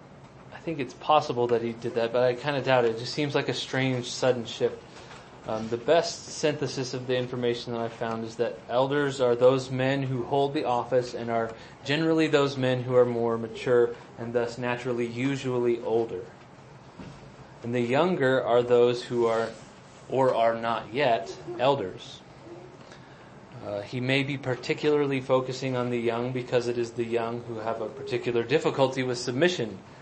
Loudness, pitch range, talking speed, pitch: -27 LUFS, 120-135 Hz, 180 wpm, 125 Hz